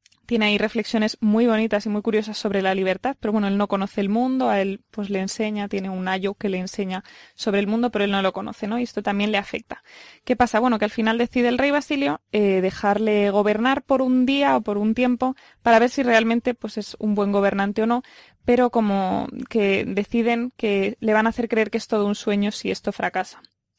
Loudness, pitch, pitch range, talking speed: -22 LUFS, 215 Hz, 205-240 Hz, 230 wpm